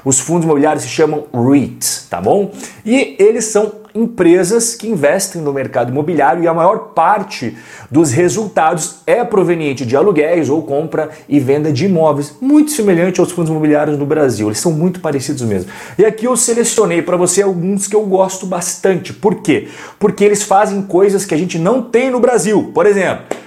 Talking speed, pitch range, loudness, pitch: 180 wpm, 155-210 Hz, -13 LUFS, 175 Hz